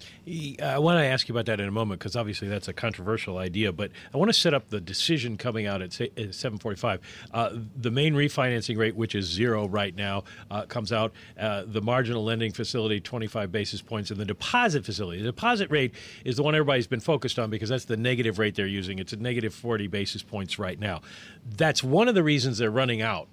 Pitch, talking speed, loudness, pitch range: 115 Hz, 220 wpm, -27 LUFS, 105-125 Hz